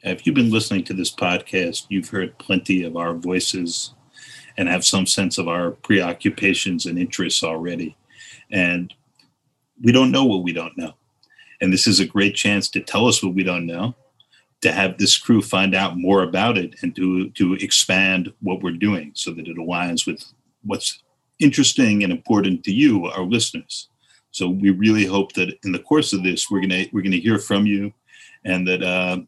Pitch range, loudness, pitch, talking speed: 90-105 Hz, -19 LUFS, 95 Hz, 195 wpm